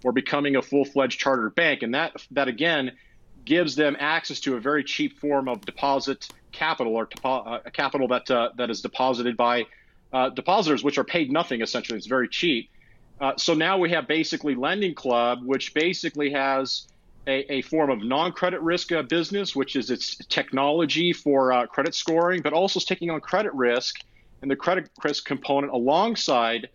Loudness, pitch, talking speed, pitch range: -24 LUFS, 140 Hz, 180 wpm, 125-160 Hz